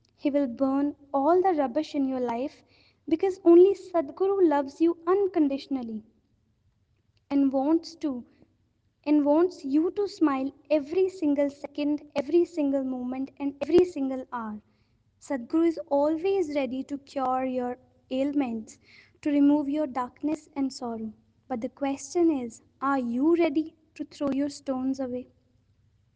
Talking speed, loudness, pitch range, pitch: 135 wpm, -27 LUFS, 260-315 Hz, 285 Hz